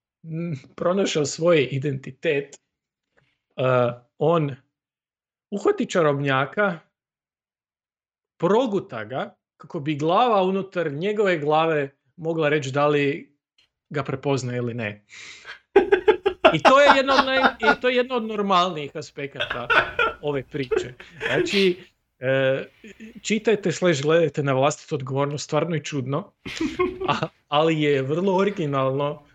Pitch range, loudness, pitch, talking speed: 140-195 Hz, -22 LUFS, 155 Hz, 110 wpm